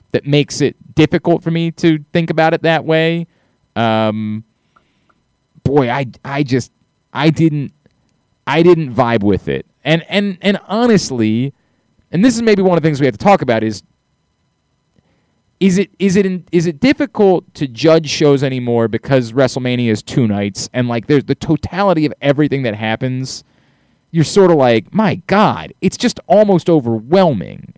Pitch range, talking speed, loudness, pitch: 125-175 Hz, 170 wpm, -14 LUFS, 150 Hz